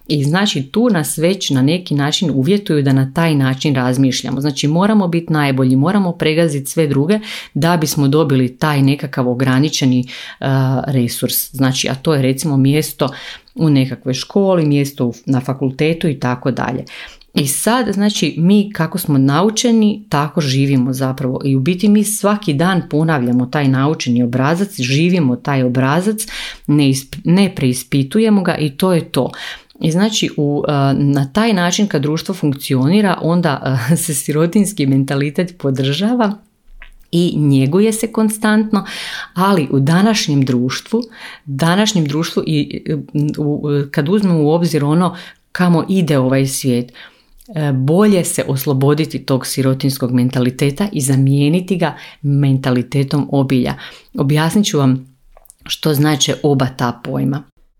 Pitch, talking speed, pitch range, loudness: 150 Hz, 135 wpm, 135-175 Hz, -15 LUFS